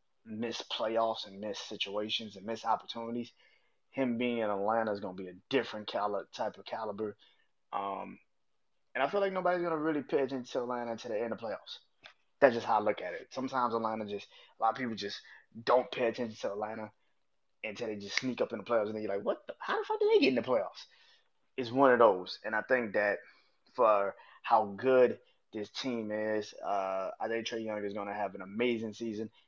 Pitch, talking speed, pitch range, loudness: 115 Hz, 220 wpm, 105-125 Hz, -33 LUFS